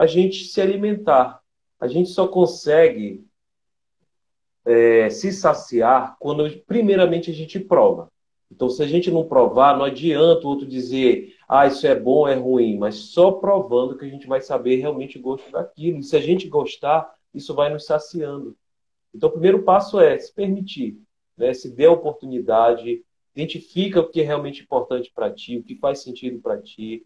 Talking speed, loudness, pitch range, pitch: 175 wpm, -19 LUFS, 130-185 Hz, 155 Hz